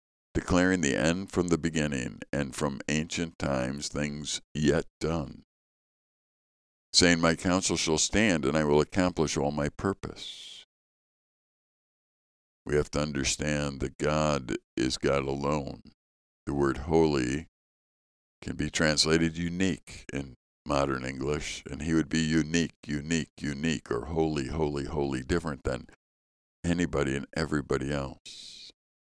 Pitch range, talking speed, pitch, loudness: 70-80 Hz, 125 wpm, 75 Hz, -29 LUFS